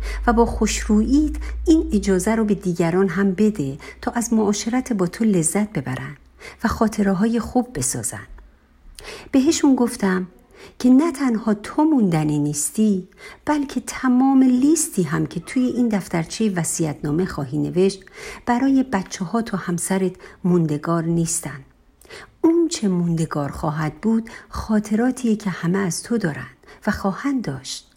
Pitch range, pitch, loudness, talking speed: 170-245 Hz, 205 Hz, -20 LUFS, 135 wpm